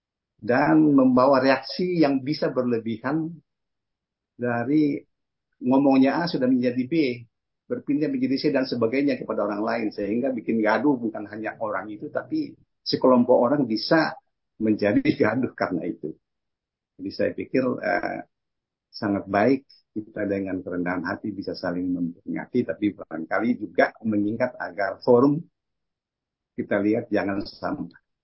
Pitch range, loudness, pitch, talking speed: 105-145 Hz, -24 LUFS, 125 Hz, 125 wpm